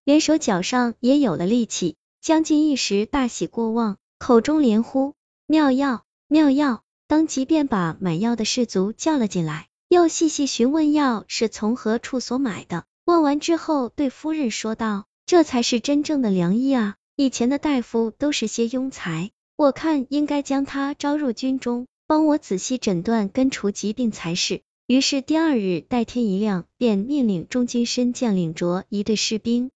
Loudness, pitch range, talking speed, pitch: -21 LUFS, 215-285 Hz, 250 characters per minute, 245 Hz